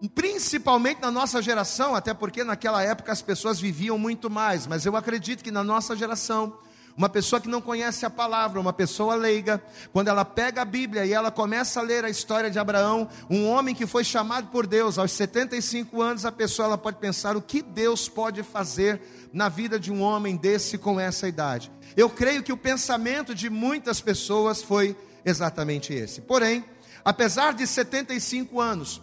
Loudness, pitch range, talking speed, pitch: -25 LUFS, 200-240 Hz, 185 wpm, 220 Hz